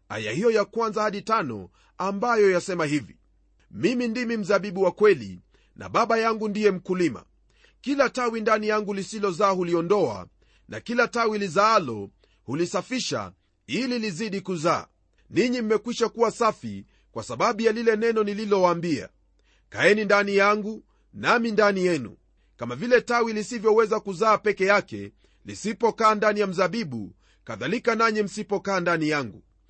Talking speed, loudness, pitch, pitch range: 130 wpm, -24 LUFS, 210 Hz, 175-225 Hz